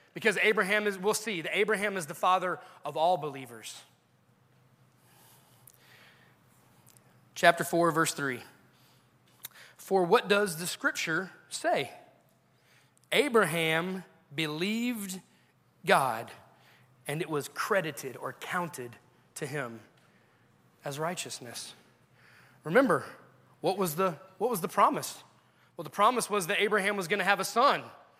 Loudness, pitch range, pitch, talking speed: -29 LUFS, 145-205 Hz, 180 Hz, 120 wpm